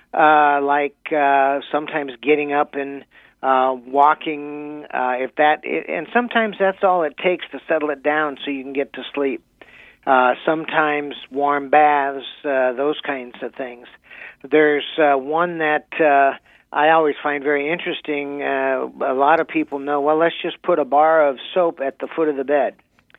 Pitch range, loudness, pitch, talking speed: 140-155 Hz, -19 LUFS, 145 Hz, 175 wpm